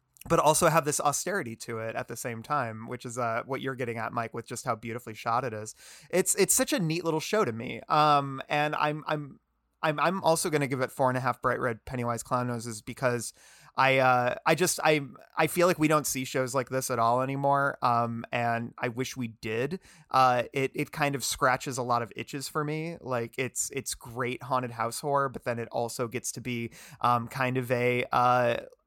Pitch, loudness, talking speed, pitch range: 130 Hz, -28 LUFS, 225 wpm, 120-150 Hz